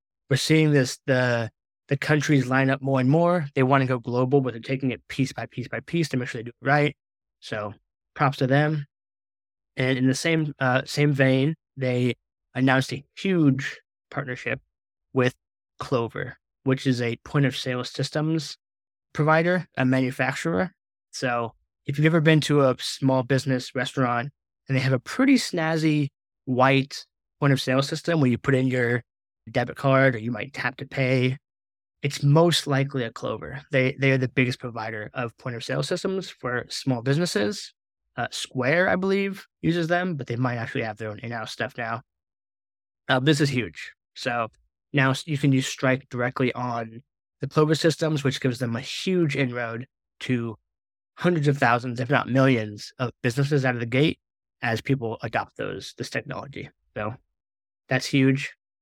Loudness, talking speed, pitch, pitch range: -24 LUFS, 175 wpm, 130 Hz, 120-145 Hz